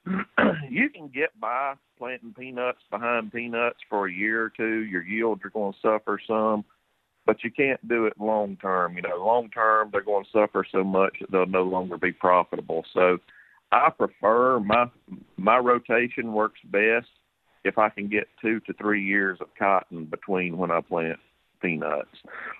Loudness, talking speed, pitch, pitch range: -25 LUFS, 170 wpm, 105 Hz, 95-115 Hz